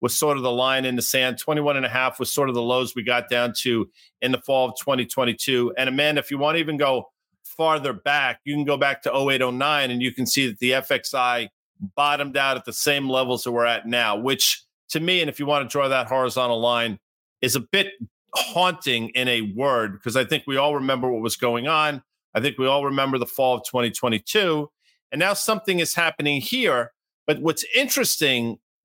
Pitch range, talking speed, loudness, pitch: 125-145 Hz, 220 wpm, -22 LUFS, 130 Hz